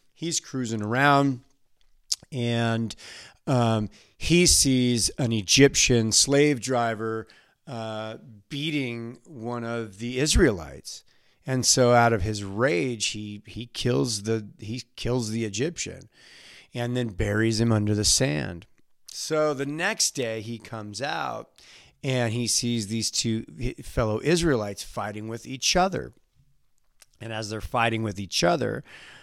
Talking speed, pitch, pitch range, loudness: 130 wpm, 115 Hz, 110-130 Hz, -24 LUFS